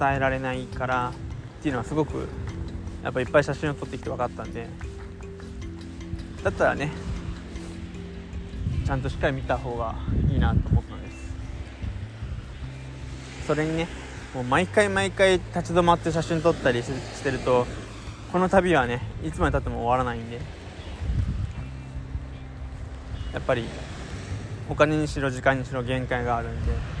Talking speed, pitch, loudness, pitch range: 295 characters per minute, 110 Hz, -27 LUFS, 85-135 Hz